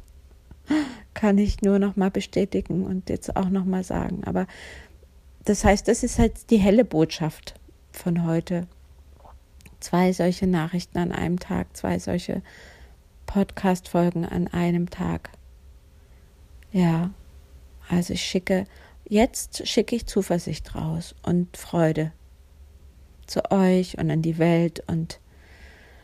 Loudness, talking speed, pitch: -24 LUFS, 120 wpm, 165 Hz